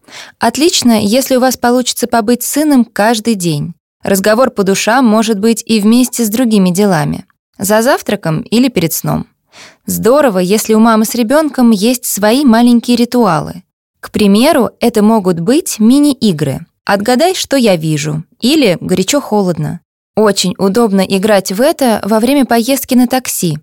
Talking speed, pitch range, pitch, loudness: 140 wpm, 200-250 Hz, 225 Hz, -11 LUFS